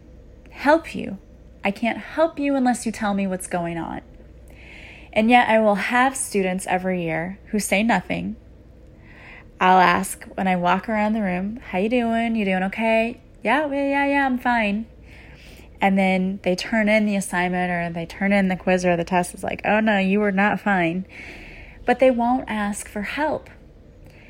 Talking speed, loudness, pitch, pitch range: 180 wpm, -21 LUFS, 205 Hz, 185-230 Hz